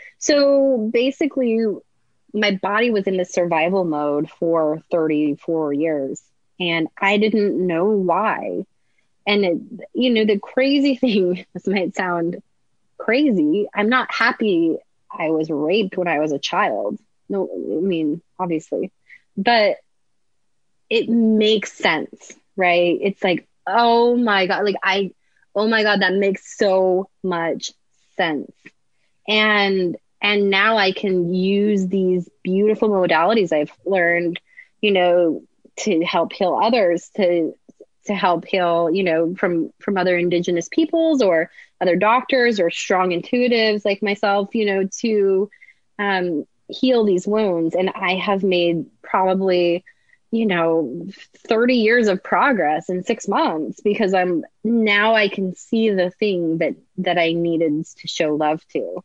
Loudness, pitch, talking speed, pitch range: -19 LUFS, 195 Hz, 135 wpm, 175-220 Hz